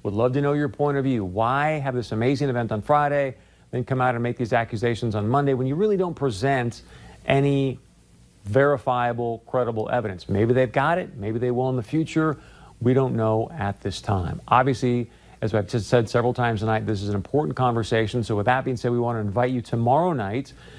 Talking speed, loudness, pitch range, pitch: 215 wpm, -23 LUFS, 110-135 Hz, 125 Hz